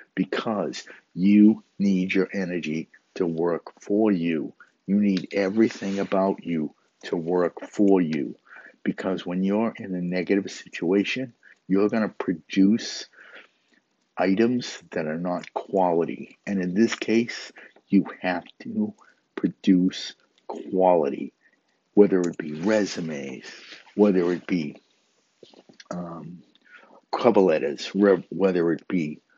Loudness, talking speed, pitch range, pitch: -24 LUFS, 115 wpm, 90-105 Hz, 95 Hz